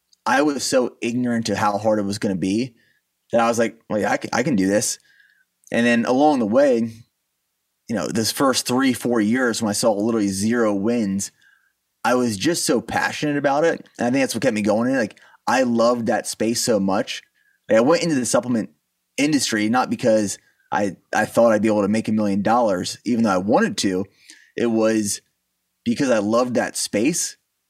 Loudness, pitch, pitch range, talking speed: -20 LUFS, 115 Hz, 105-150 Hz, 210 wpm